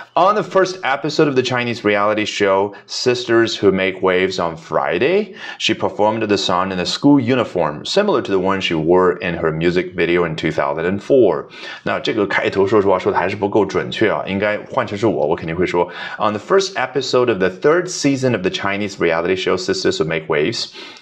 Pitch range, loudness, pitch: 90-130 Hz, -17 LUFS, 100 Hz